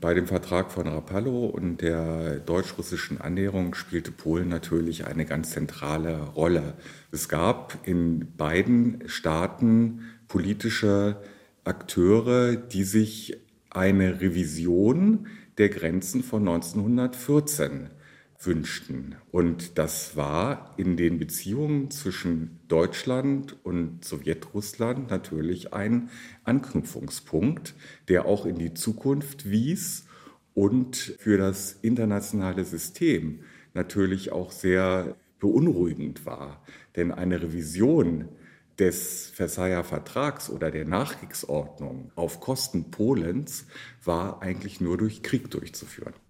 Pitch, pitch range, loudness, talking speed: 95 Hz, 85-110 Hz, -27 LUFS, 100 wpm